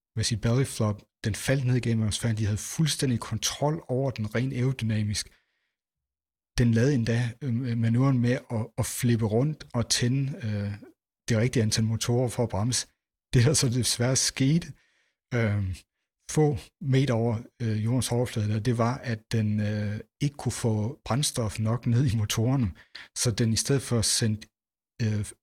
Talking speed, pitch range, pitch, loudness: 160 wpm, 110-125 Hz, 115 Hz, -27 LUFS